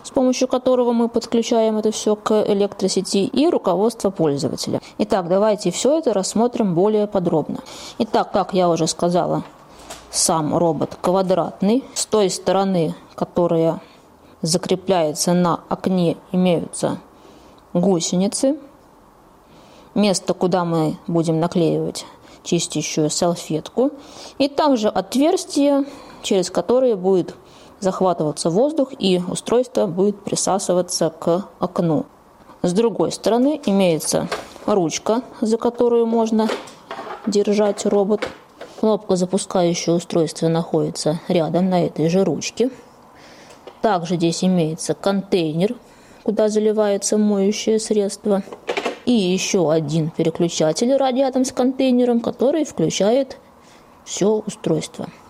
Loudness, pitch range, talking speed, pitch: -19 LUFS, 175-230 Hz, 105 wpm, 195 Hz